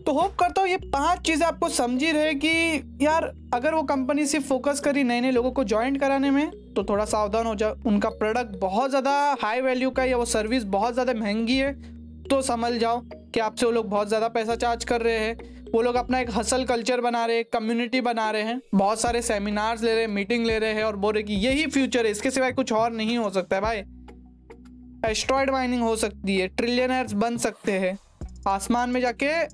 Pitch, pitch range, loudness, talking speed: 240 Hz, 220-265 Hz, -24 LUFS, 225 wpm